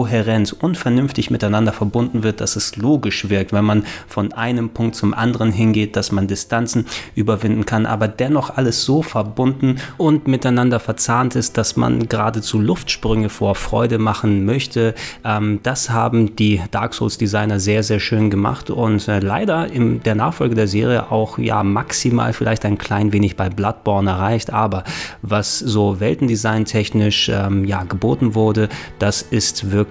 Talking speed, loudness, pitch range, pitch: 160 wpm, -18 LUFS, 105-115 Hz, 110 Hz